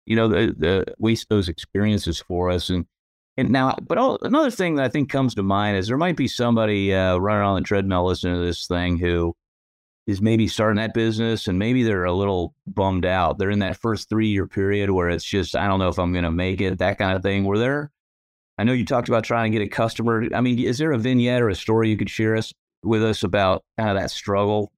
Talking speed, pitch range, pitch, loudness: 245 wpm, 90-115 Hz, 105 Hz, -22 LUFS